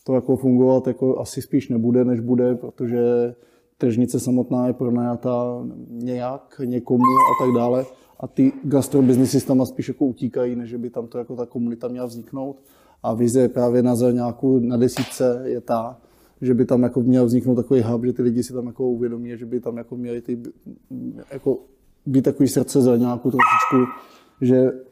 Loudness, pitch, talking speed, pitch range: -20 LUFS, 125 Hz, 175 wpm, 120-130 Hz